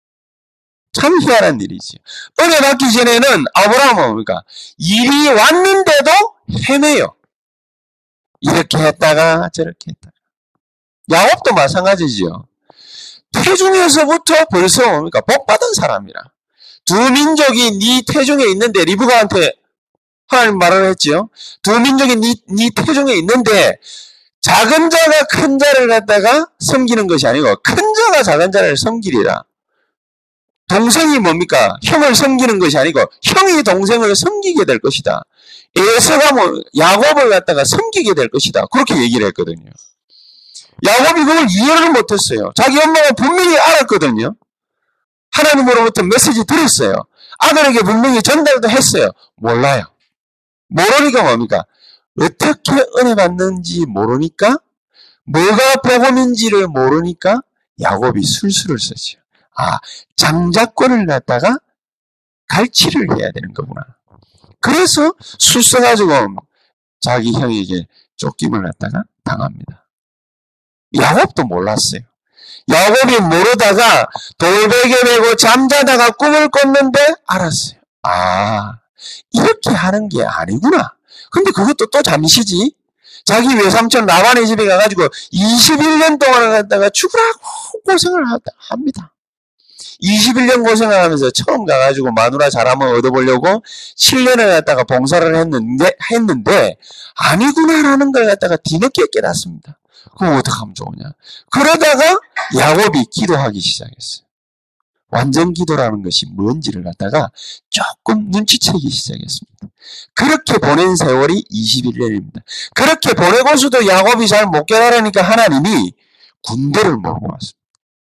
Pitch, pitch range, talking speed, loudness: 240 Hz, 180-300 Hz, 285 characters per minute, -11 LUFS